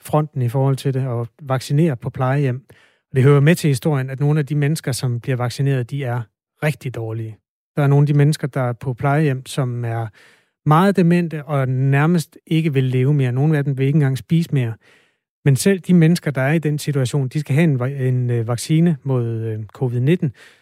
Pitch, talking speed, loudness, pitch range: 140 Hz, 205 wpm, -19 LUFS, 125-150 Hz